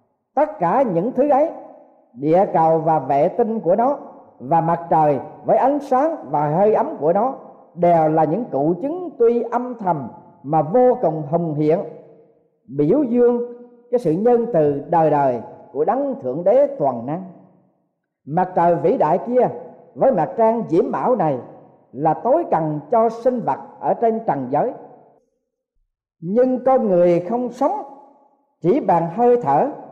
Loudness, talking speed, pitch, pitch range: -19 LUFS, 160 wpm, 225 Hz, 160-255 Hz